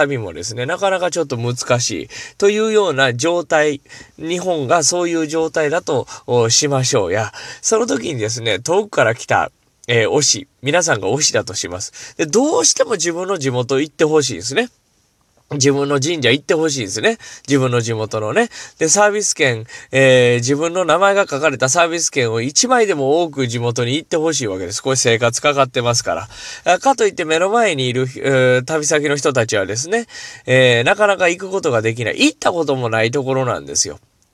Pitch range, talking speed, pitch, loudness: 120-175 Hz, 385 characters per minute, 145 Hz, -16 LUFS